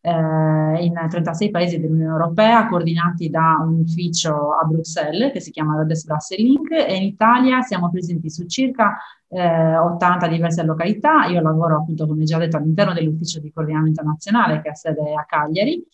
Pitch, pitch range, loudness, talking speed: 165 Hz, 155-185 Hz, -18 LUFS, 165 wpm